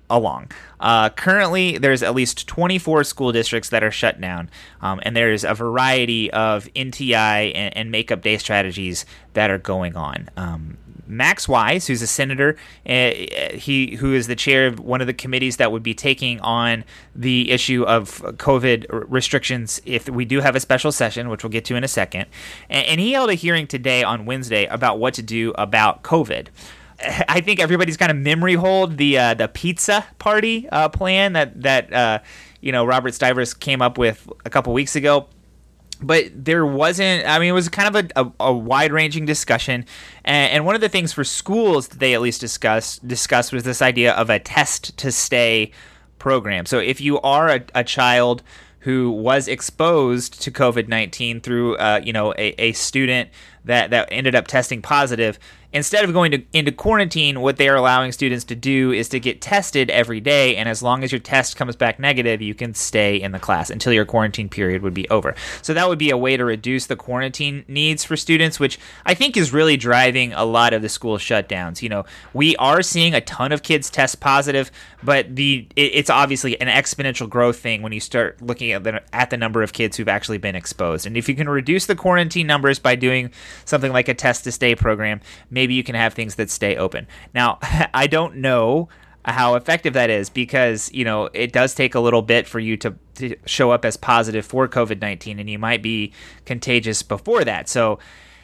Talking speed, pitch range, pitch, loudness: 210 wpm, 115-140 Hz, 125 Hz, -18 LUFS